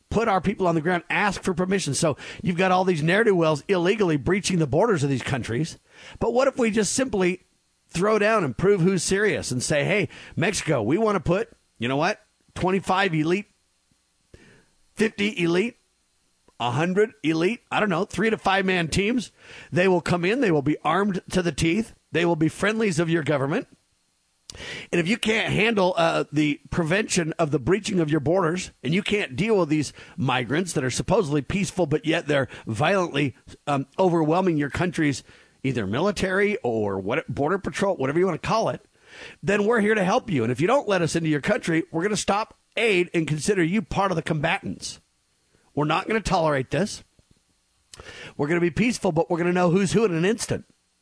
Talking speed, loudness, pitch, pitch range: 200 wpm, -23 LUFS, 175 Hz, 150-195 Hz